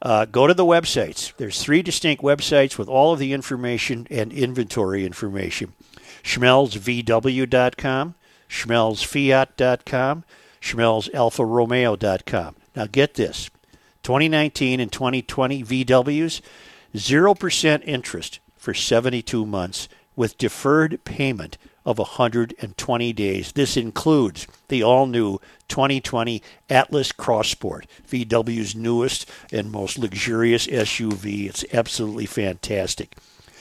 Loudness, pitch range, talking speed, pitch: -21 LUFS, 110-135 Hz, 100 wpm, 125 Hz